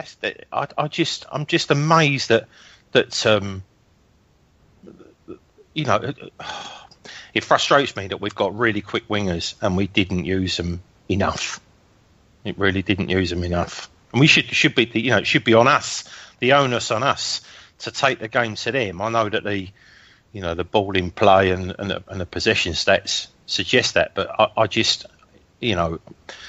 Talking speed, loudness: 180 wpm, -20 LUFS